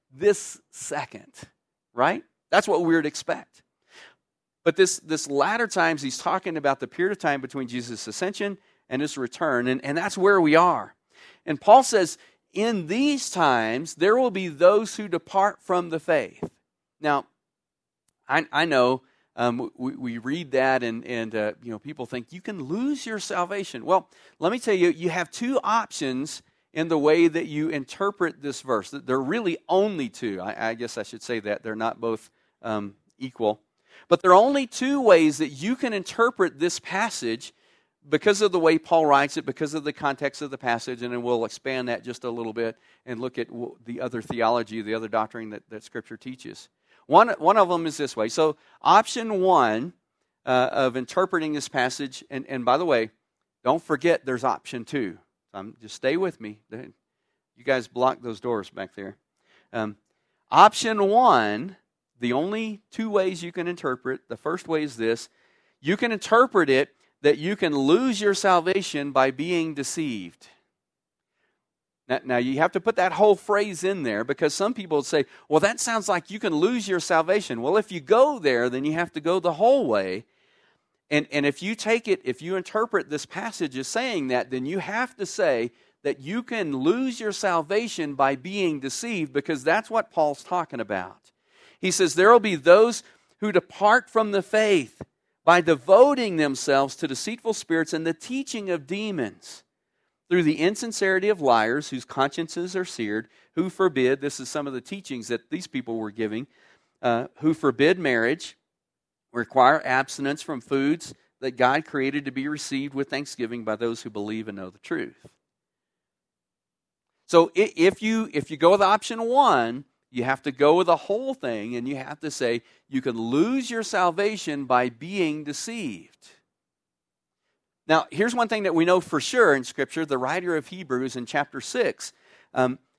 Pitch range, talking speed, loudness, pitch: 130-195 Hz, 180 wpm, -24 LUFS, 155 Hz